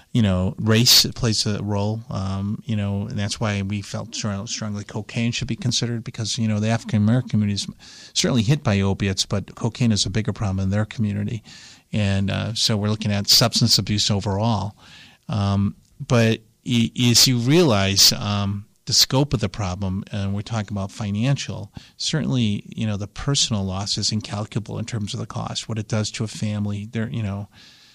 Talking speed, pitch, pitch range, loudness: 185 wpm, 110 Hz, 100-115 Hz, -21 LUFS